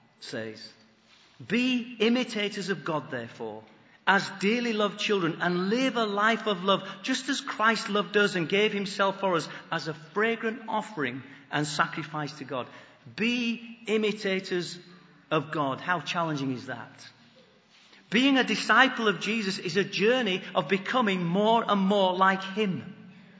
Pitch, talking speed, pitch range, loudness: 195 Hz, 145 wpm, 165-215 Hz, -27 LUFS